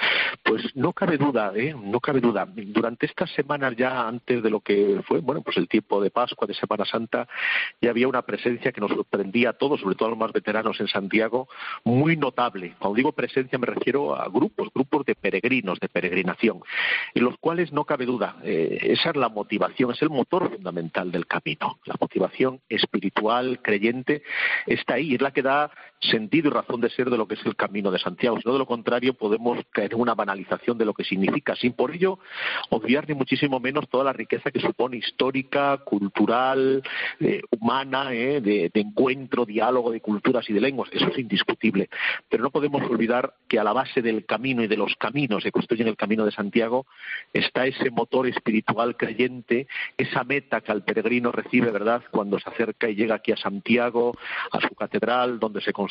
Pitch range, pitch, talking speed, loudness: 110-130 Hz, 120 Hz, 200 wpm, -24 LUFS